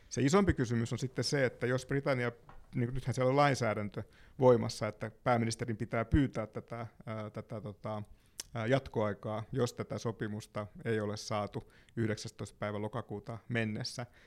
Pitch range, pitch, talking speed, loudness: 110-125 Hz, 115 Hz, 135 wpm, -35 LUFS